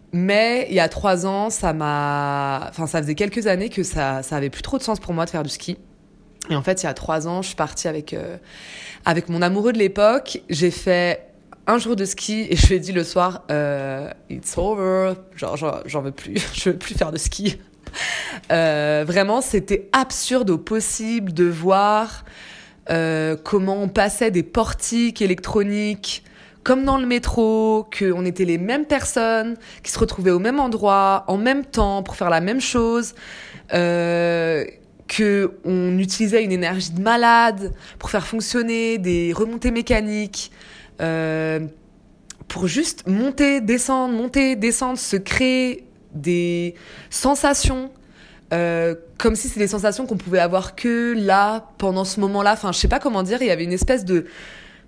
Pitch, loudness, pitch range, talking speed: 195 Hz, -20 LUFS, 175-230 Hz, 175 wpm